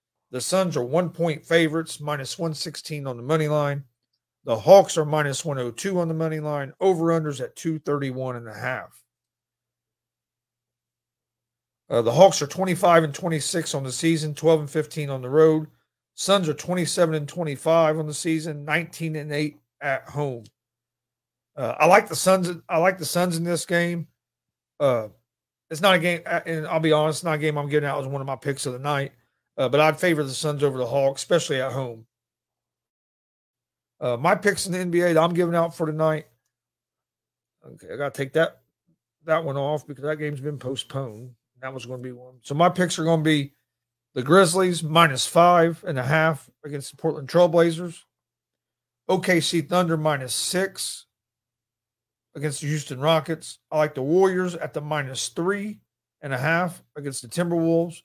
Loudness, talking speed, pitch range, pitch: -23 LUFS, 180 wpm, 130-165 Hz, 155 Hz